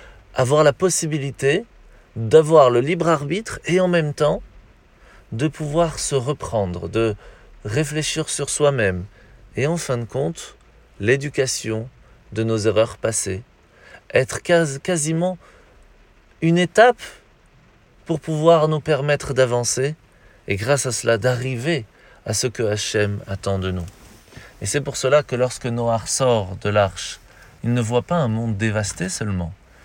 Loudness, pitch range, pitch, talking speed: -20 LUFS, 105-155 Hz, 125 Hz, 140 wpm